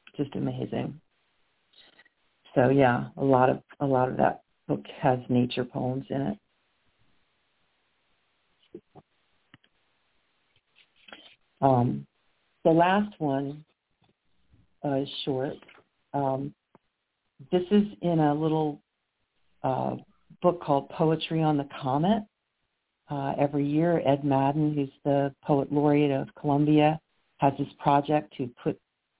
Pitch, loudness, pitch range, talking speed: 140 Hz, -27 LUFS, 135-155 Hz, 110 wpm